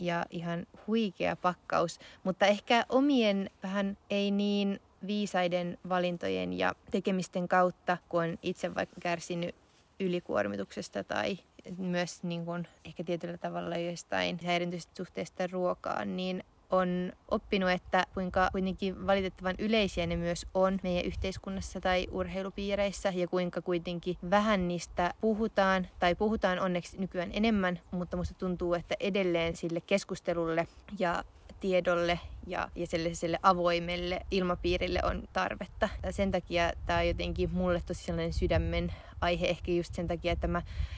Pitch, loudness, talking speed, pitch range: 180 Hz, -32 LUFS, 130 wpm, 175-190 Hz